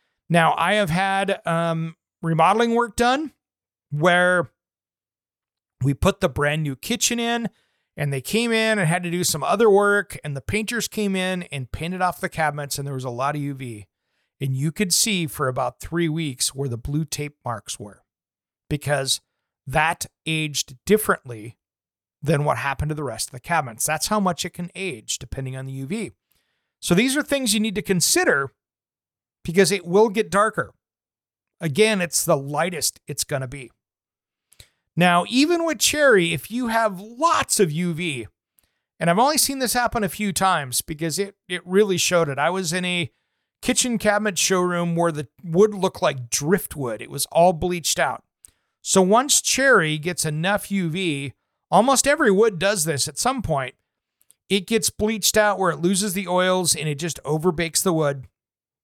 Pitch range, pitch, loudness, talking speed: 145-205 Hz, 175 Hz, -21 LUFS, 175 wpm